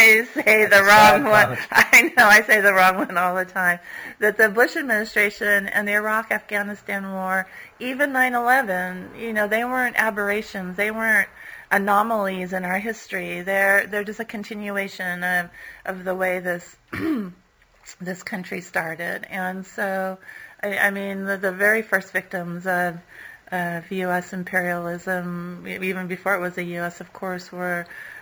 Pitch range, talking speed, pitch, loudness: 185-215 Hz, 155 wpm, 195 Hz, -20 LUFS